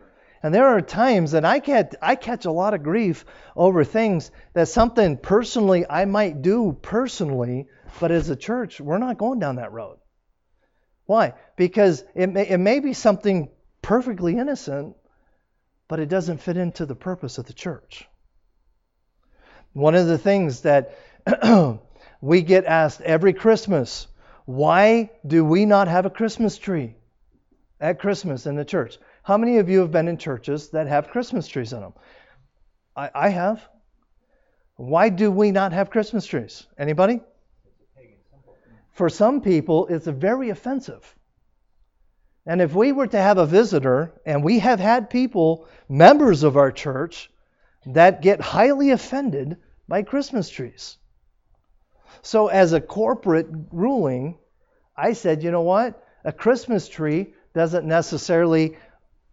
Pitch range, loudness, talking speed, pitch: 150-215 Hz, -20 LUFS, 150 wpm, 180 Hz